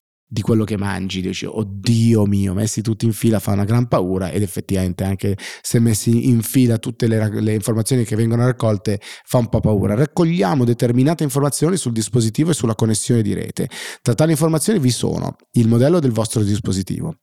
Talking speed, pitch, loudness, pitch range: 185 wpm, 115 Hz, -18 LUFS, 105-125 Hz